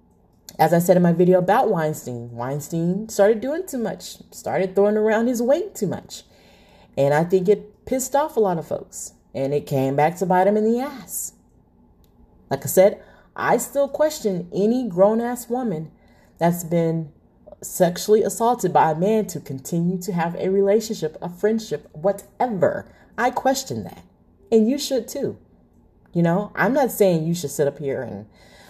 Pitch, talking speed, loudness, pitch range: 190 Hz, 175 wpm, -21 LUFS, 155-220 Hz